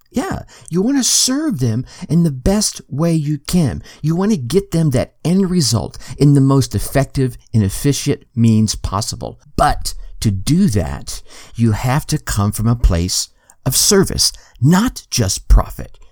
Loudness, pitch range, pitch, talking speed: -16 LUFS, 115-170 Hz, 135 Hz, 165 wpm